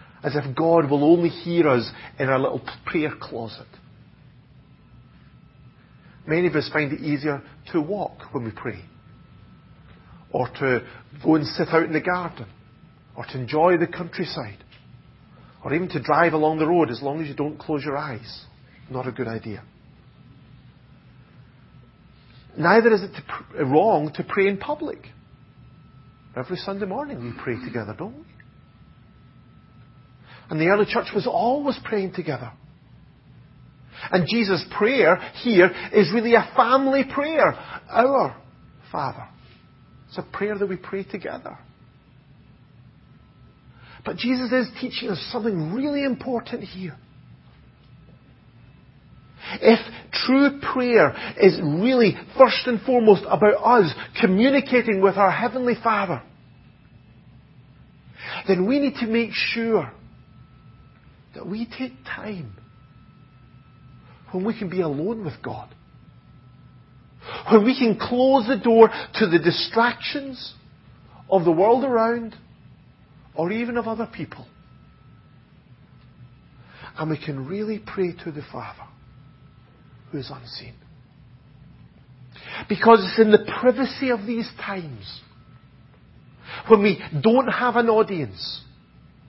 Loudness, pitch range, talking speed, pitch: -21 LUFS, 140-225 Hz, 125 wpm, 175 Hz